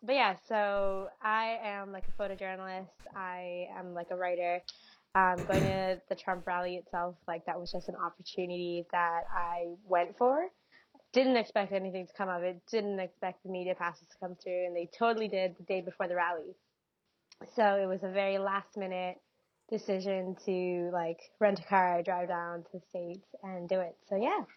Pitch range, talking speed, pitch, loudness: 180-195 Hz, 190 wpm, 185 Hz, -34 LUFS